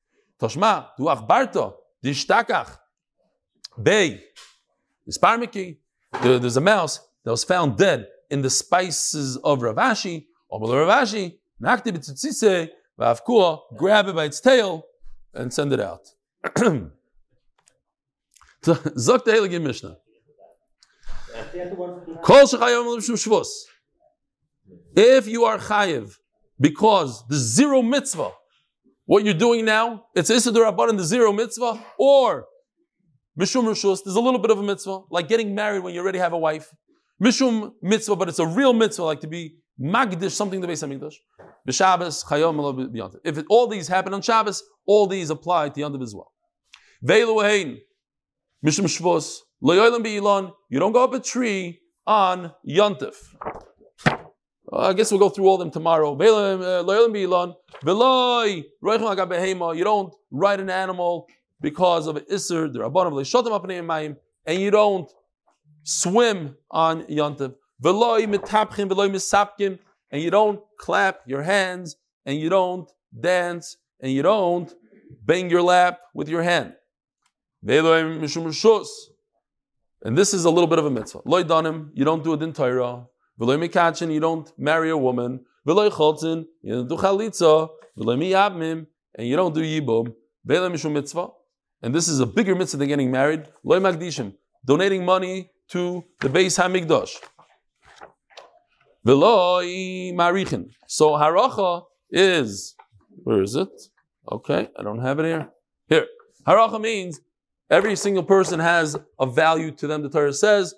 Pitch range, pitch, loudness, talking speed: 160-210 Hz, 180 Hz, -21 LUFS, 130 wpm